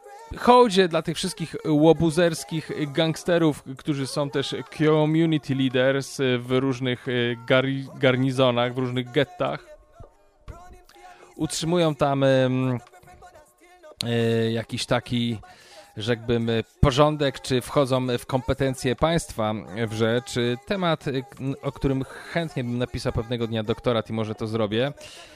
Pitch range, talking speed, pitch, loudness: 120-155 Hz, 110 wpm, 135 Hz, -24 LUFS